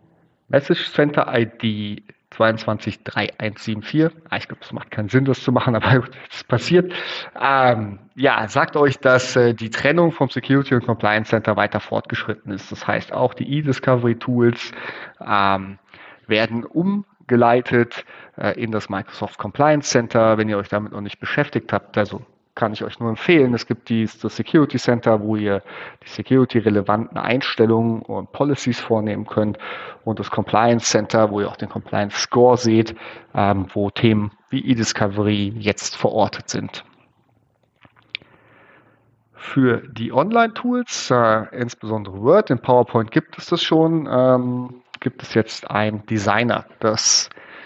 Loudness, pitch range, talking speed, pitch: -19 LUFS, 105-130 Hz, 135 wpm, 115 Hz